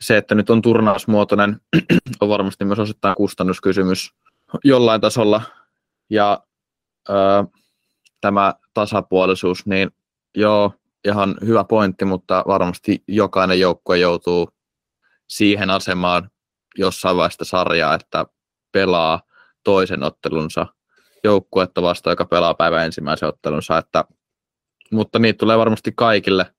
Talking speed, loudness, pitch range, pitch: 110 wpm, -18 LUFS, 95-105 Hz, 100 Hz